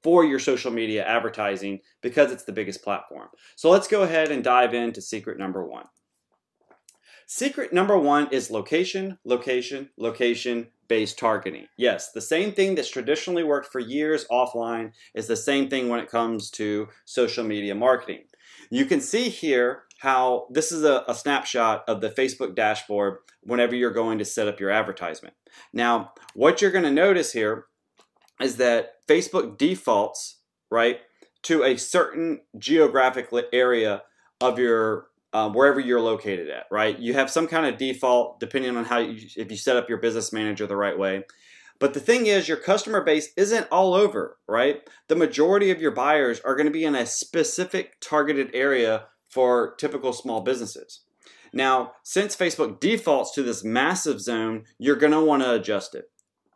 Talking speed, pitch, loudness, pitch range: 170 wpm, 125 Hz, -23 LUFS, 115-155 Hz